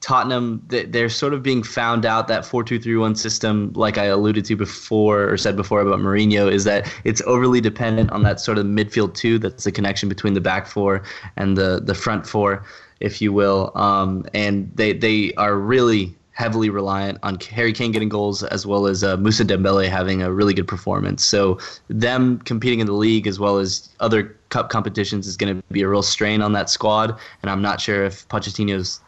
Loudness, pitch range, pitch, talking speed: -19 LUFS, 100-110 Hz, 105 Hz, 200 wpm